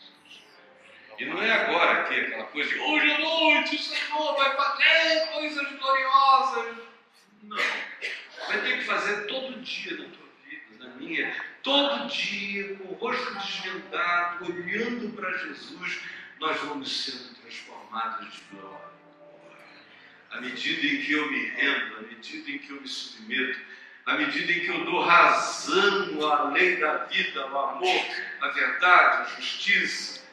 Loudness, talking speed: -25 LUFS, 150 wpm